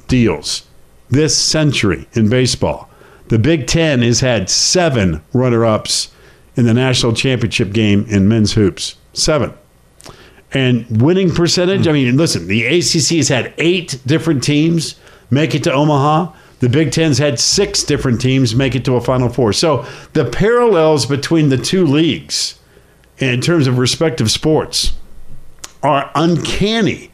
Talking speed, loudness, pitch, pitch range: 145 wpm, -14 LUFS, 130 Hz, 115-160 Hz